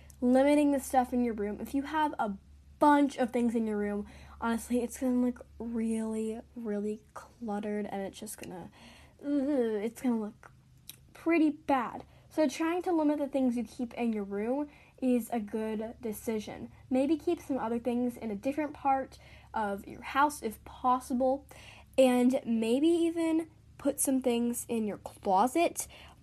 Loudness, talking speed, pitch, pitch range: -31 LUFS, 160 wpm, 245 Hz, 225-280 Hz